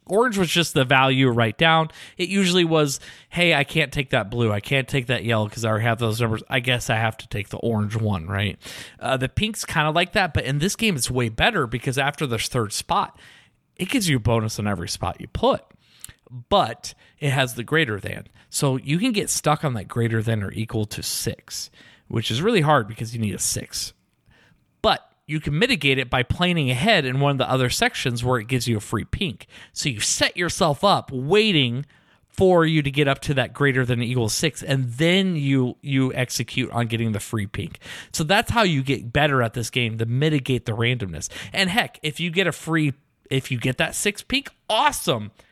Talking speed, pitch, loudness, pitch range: 220 wpm, 130 Hz, -22 LUFS, 115-155 Hz